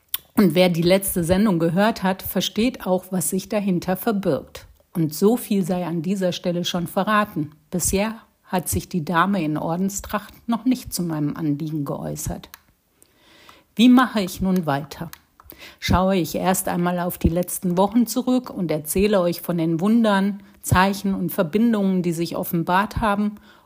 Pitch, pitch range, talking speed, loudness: 185 Hz, 175-205 Hz, 155 wpm, -21 LUFS